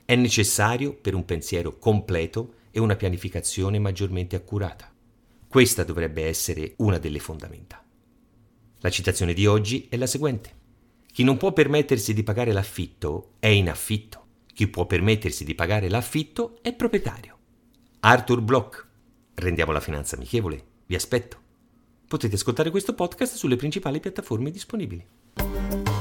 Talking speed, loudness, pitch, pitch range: 135 wpm, -24 LUFS, 110 Hz, 90-125 Hz